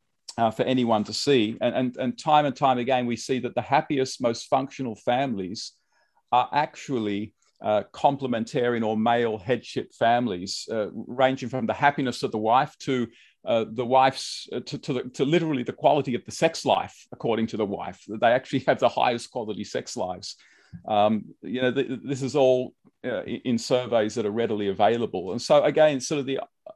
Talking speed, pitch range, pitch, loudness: 185 wpm, 115-135 Hz, 125 Hz, -25 LUFS